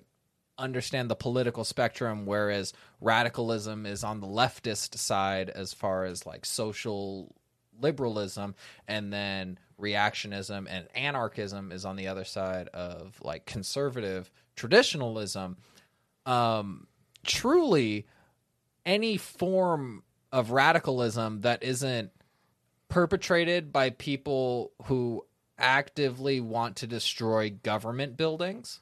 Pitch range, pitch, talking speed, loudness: 100-130 Hz, 115 Hz, 100 wpm, -30 LUFS